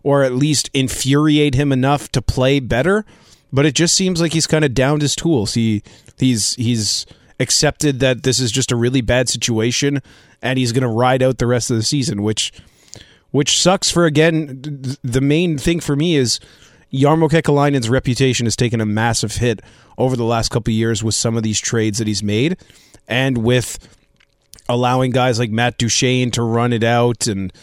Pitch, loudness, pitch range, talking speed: 125 Hz, -16 LUFS, 115-145 Hz, 195 wpm